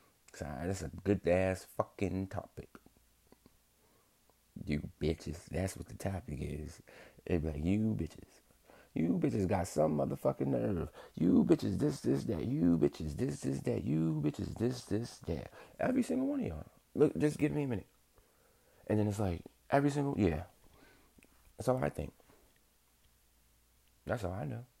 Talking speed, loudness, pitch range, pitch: 155 wpm, -35 LUFS, 75-110 Hz, 90 Hz